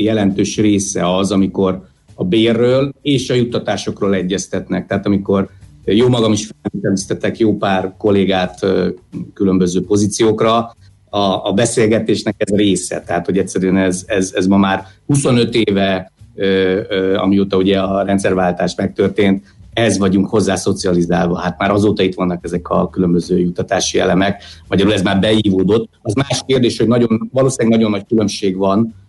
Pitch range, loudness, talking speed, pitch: 95-110 Hz, -15 LUFS, 150 wpm, 100 Hz